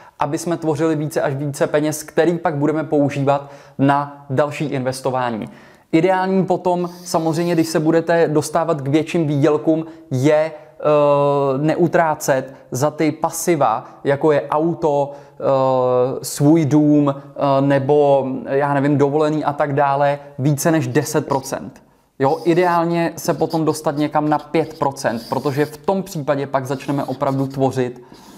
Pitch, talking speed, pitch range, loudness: 150 Hz, 135 wpm, 140-160 Hz, -18 LUFS